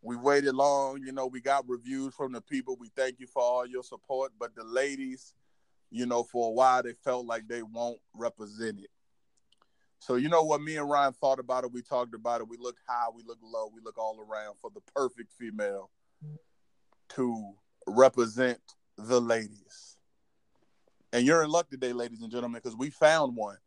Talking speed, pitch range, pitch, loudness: 195 wpm, 115-135 Hz, 125 Hz, -30 LUFS